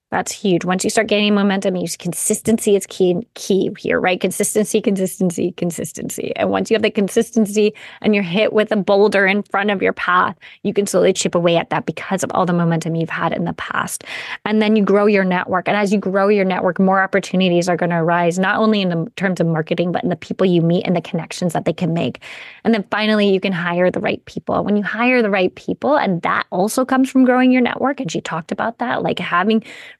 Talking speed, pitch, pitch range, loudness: 240 wpm, 195 Hz, 180-215 Hz, -17 LUFS